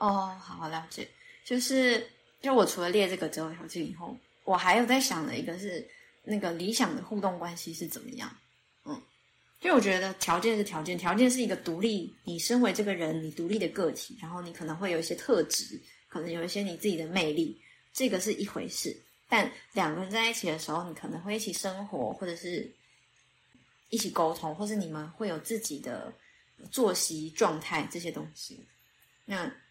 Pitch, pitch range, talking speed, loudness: 190 Hz, 170-230 Hz, 290 characters per minute, -31 LUFS